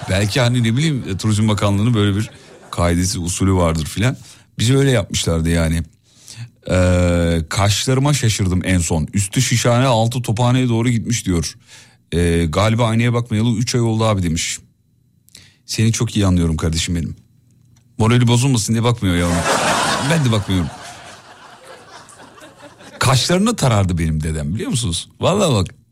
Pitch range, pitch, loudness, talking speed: 90-120 Hz, 110 Hz, -17 LUFS, 135 wpm